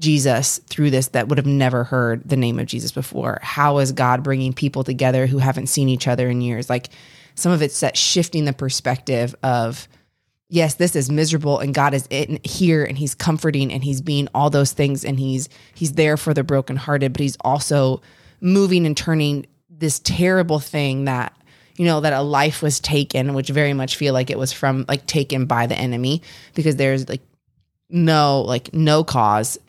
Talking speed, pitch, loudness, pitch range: 195 wpm, 140 Hz, -19 LUFS, 130-150 Hz